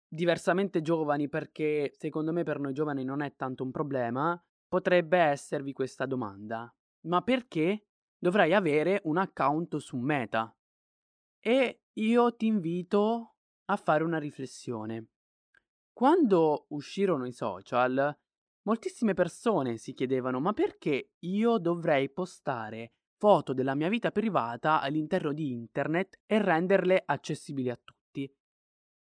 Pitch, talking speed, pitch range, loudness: 155 Hz, 120 wpm, 130-185 Hz, -29 LUFS